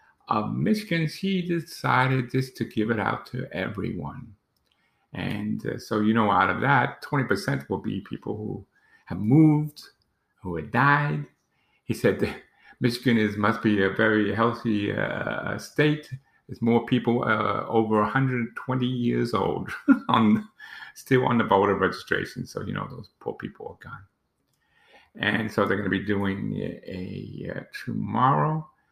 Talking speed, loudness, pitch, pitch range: 155 wpm, -25 LUFS, 120 Hz, 105-140 Hz